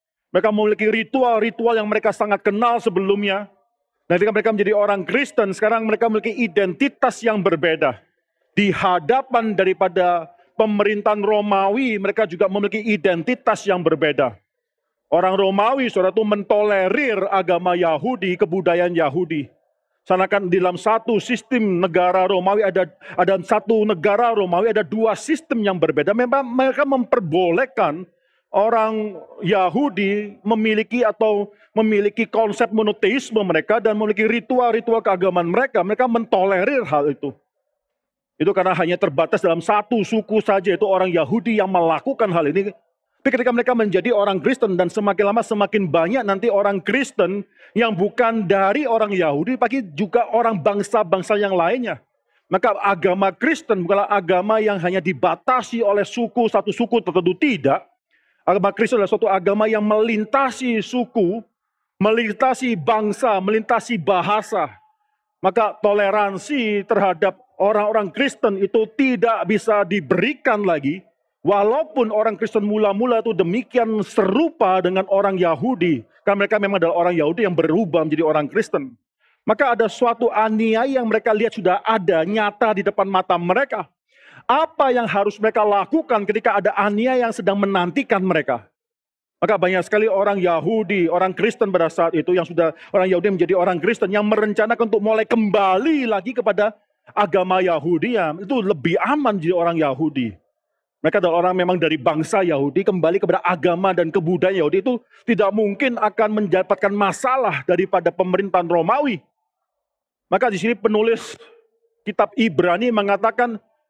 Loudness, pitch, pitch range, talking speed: -19 LUFS, 210 Hz, 185-230 Hz, 135 wpm